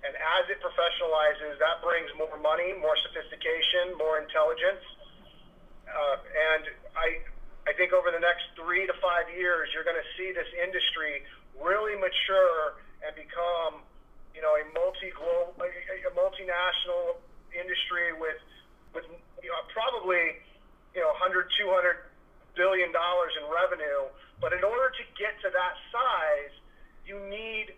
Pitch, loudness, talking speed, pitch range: 180 Hz, -28 LUFS, 145 wpm, 160-205 Hz